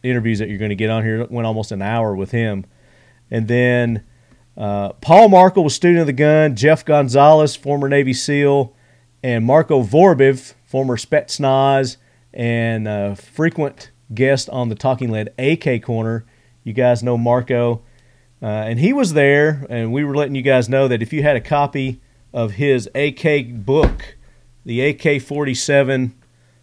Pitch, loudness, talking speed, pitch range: 125 Hz, -16 LUFS, 160 wpm, 115-140 Hz